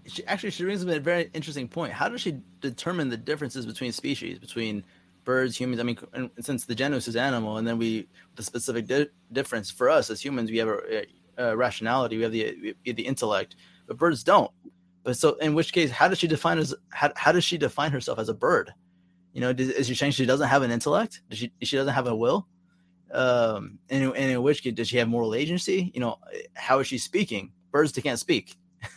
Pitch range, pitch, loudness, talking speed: 115-150 Hz, 130 Hz, -26 LUFS, 230 wpm